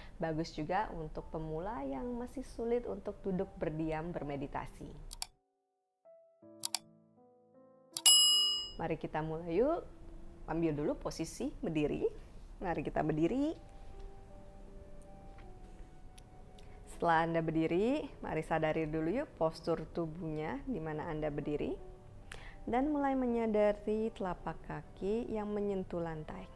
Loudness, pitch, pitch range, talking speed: -35 LUFS, 165 Hz, 155-245 Hz, 95 wpm